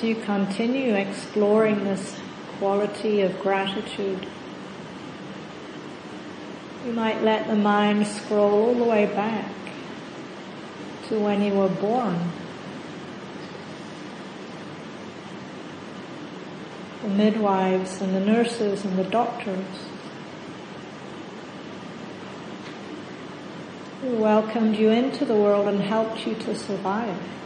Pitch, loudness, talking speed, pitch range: 210 Hz, -24 LUFS, 90 wpm, 195-220 Hz